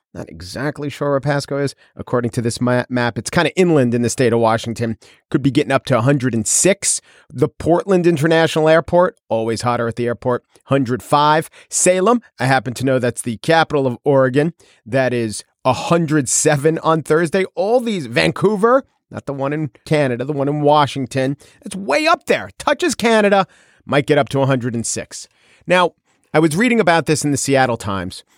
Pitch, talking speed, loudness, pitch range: 140 Hz, 175 wpm, -17 LUFS, 120-165 Hz